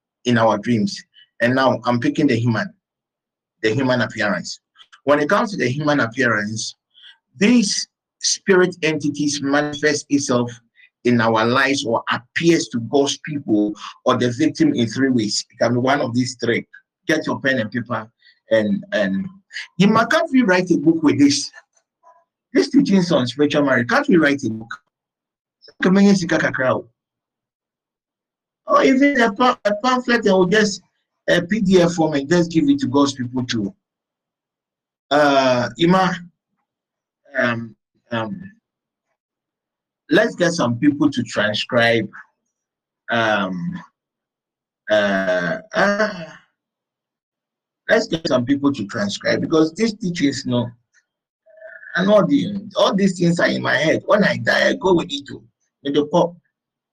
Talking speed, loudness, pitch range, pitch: 140 wpm, -18 LUFS, 120-200 Hz, 150 Hz